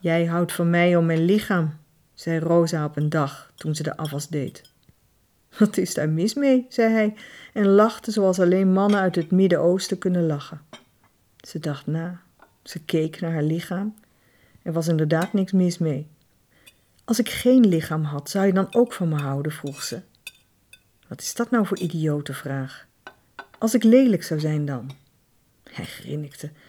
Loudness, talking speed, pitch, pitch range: -22 LUFS, 175 wpm, 170 Hz, 150-195 Hz